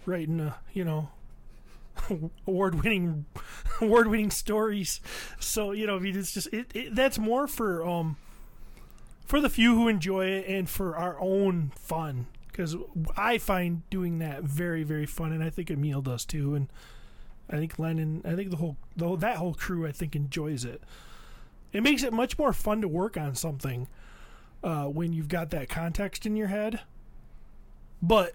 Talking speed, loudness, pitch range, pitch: 165 wpm, -29 LUFS, 160-205 Hz, 175 Hz